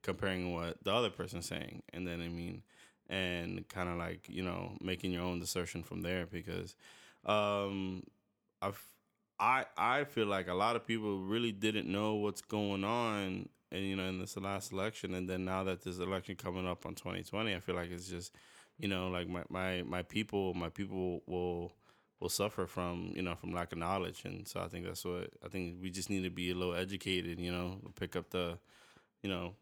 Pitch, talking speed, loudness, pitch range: 90 Hz, 210 wpm, -38 LUFS, 90-100 Hz